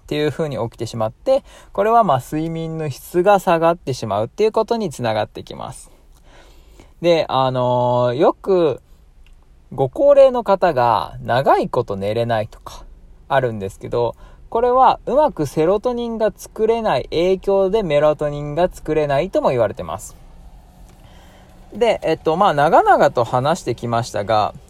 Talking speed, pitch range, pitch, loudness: 300 characters per minute, 115-195 Hz, 150 Hz, -18 LUFS